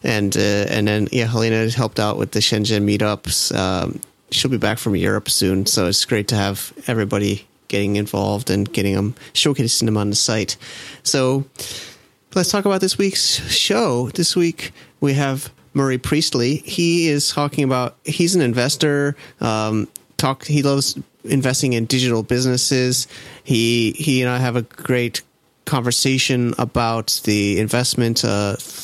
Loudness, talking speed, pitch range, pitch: -18 LUFS, 155 wpm, 105-140 Hz, 120 Hz